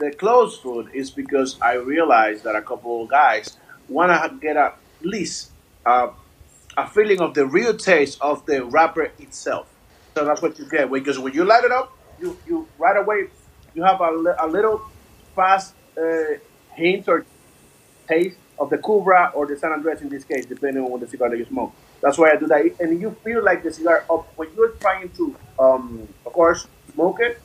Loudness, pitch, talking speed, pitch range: -20 LUFS, 160 Hz, 205 wpm, 135-195 Hz